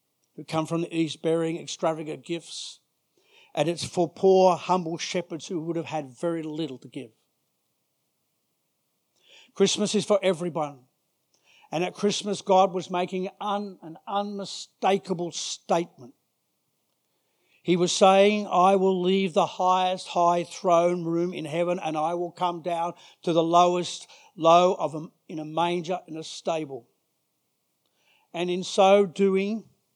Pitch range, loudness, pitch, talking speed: 165-190 Hz, -25 LUFS, 175 Hz, 135 wpm